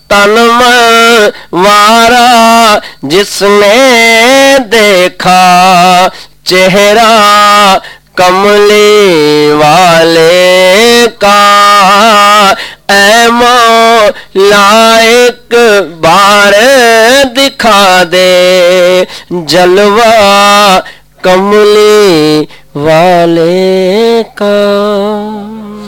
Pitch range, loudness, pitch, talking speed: 185-225 Hz, -3 LUFS, 205 Hz, 45 wpm